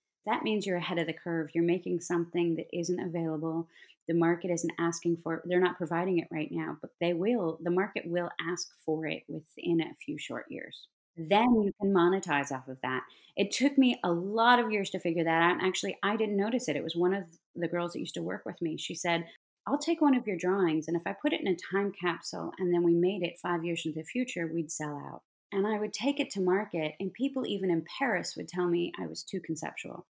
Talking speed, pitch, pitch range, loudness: 245 wpm, 175 Hz, 165-195 Hz, -31 LUFS